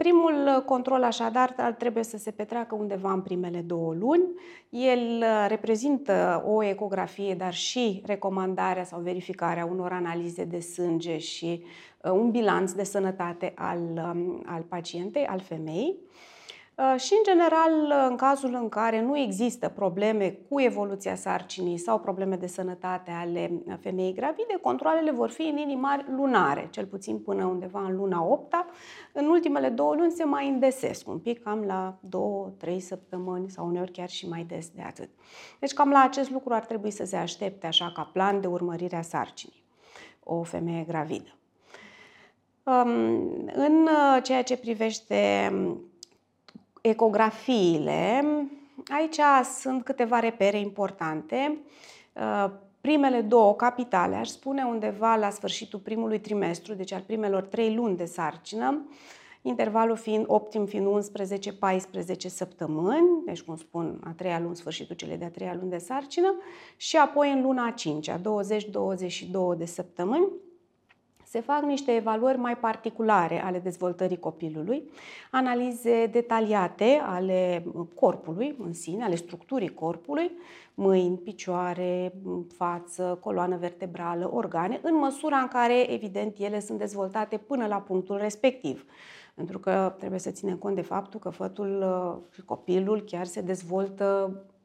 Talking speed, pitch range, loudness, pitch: 140 wpm, 180-255 Hz, -27 LUFS, 200 Hz